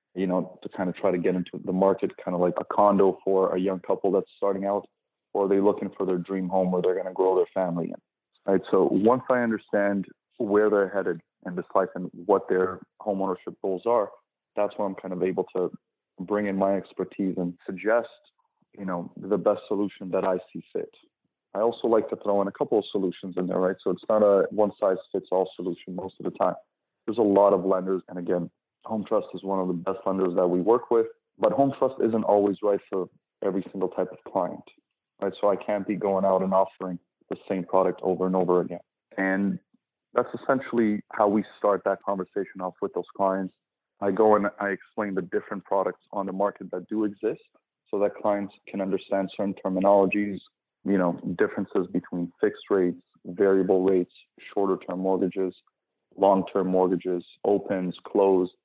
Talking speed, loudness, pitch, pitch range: 205 wpm, -26 LUFS, 95 Hz, 95-100 Hz